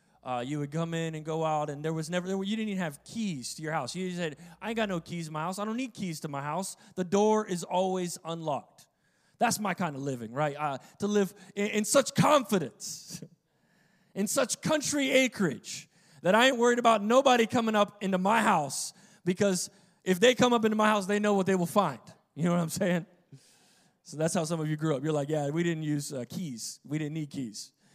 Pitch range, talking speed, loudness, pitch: 160-205 Hz, 235 wpm, -29 LUFS, 180 Hz